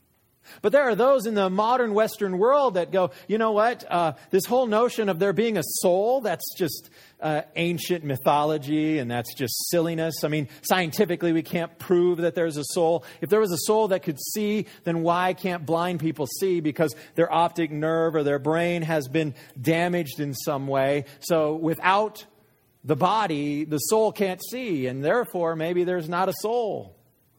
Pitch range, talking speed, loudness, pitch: 155-195 Hz, 185 wpm, -24 LUFS, 170 Hz